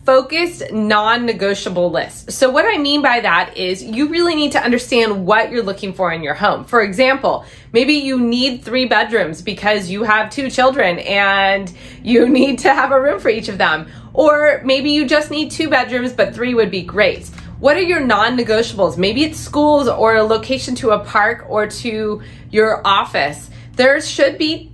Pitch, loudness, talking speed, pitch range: 235 Hz, -15 LUFS, 190 wpm, 210-275 Hz